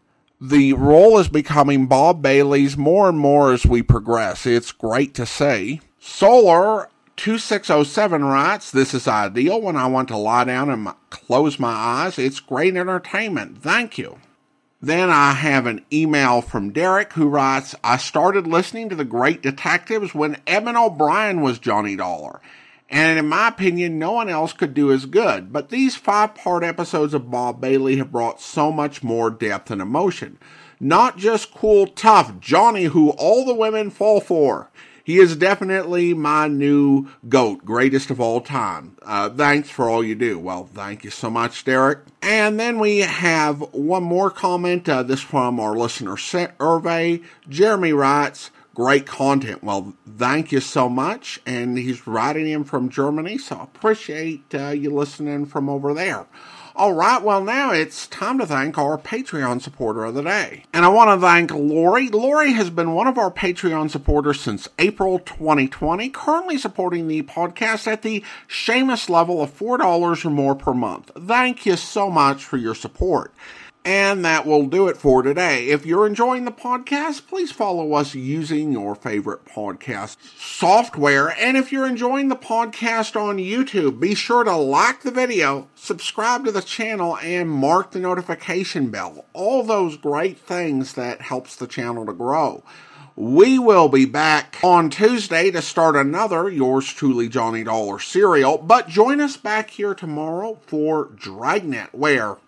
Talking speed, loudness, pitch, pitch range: 165 wpm, -18 LUFS, 155 Hz, 135-200 Hz